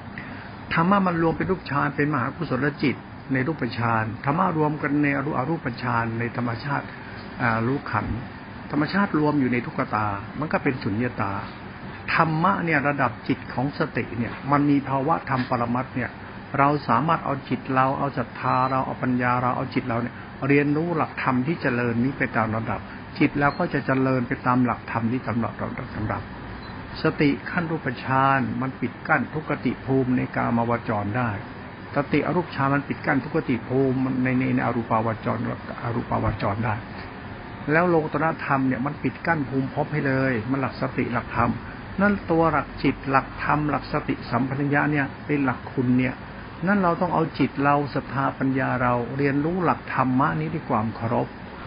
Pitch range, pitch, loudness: 120-145 Hz, 130 Hz, -24 LUFS